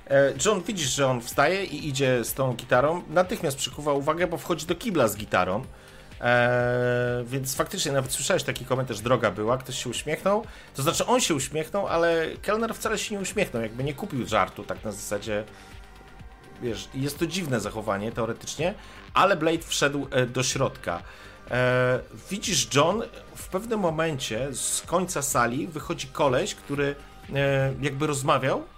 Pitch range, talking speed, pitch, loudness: 120-165 Hz, 160 wpm, 135 Hz, -26 LUFS